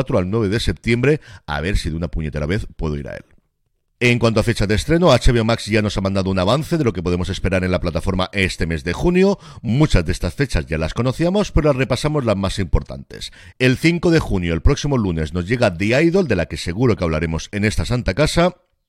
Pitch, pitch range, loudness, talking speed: 105 Hz, 90-130 Hz, -19 LUFS, 240 wpm